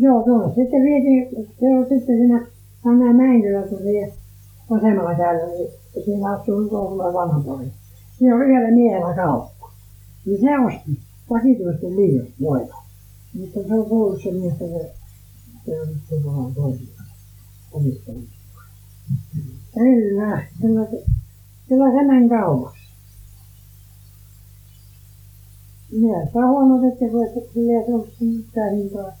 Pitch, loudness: 175 Hz, -19 LUFS